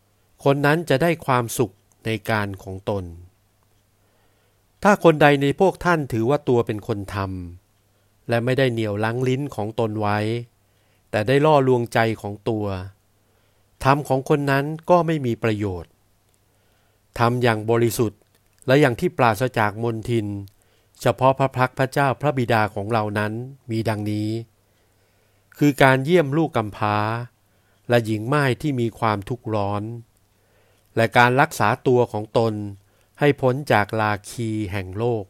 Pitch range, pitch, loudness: 105-130 Hz, 110 Hz, -21 LUFS